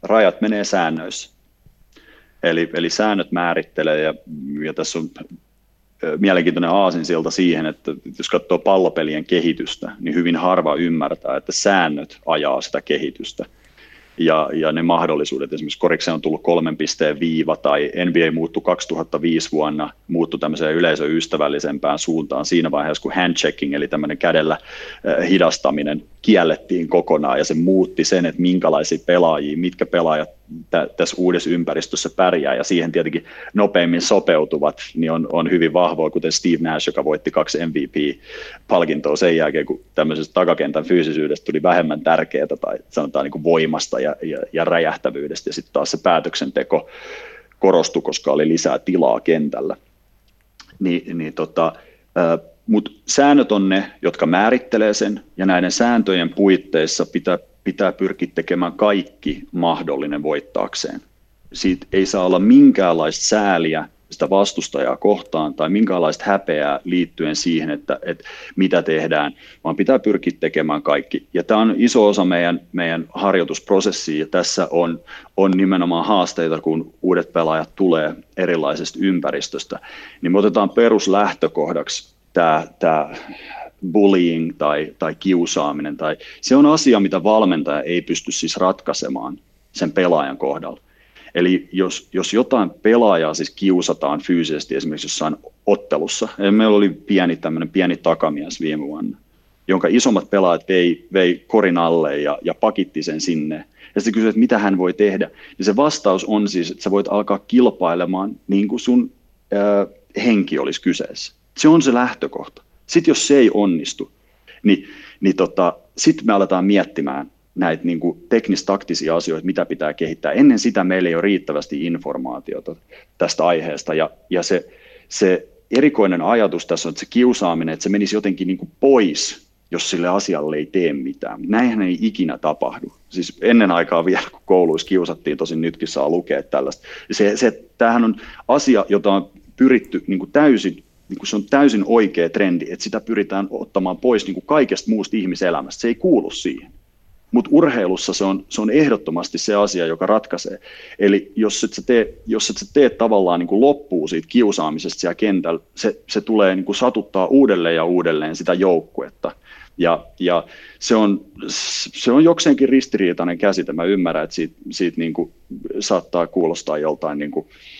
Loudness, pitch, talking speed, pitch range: -18 LUFS, 90 Hz, 150 wpm, 80-105 Hz